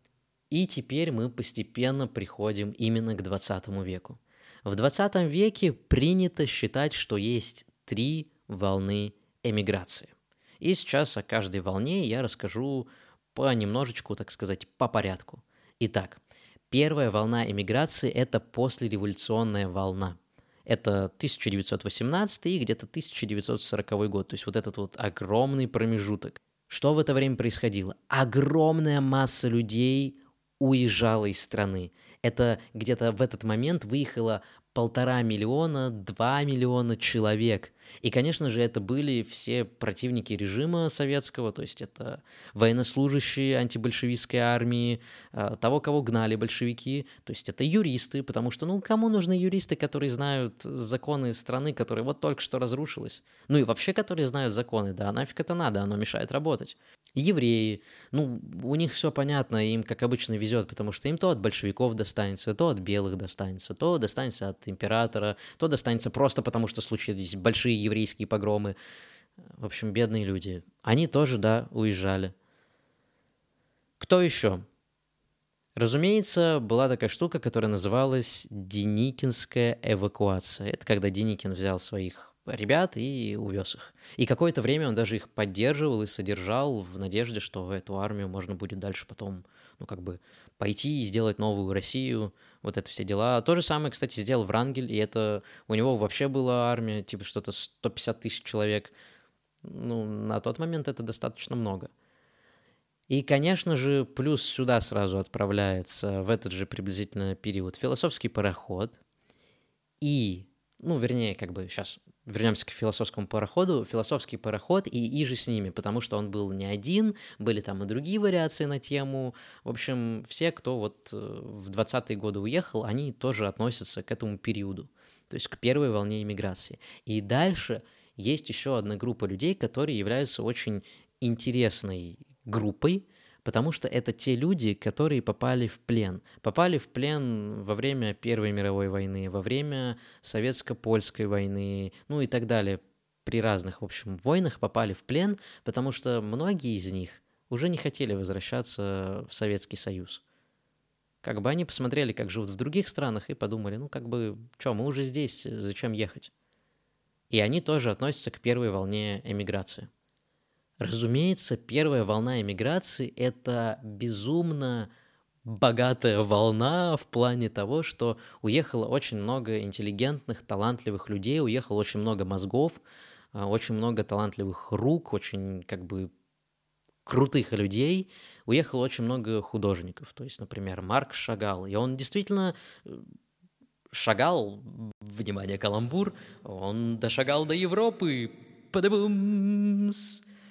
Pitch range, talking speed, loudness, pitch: 105-135 Hz, 140 wpm, -29 LUFS, 115 Hz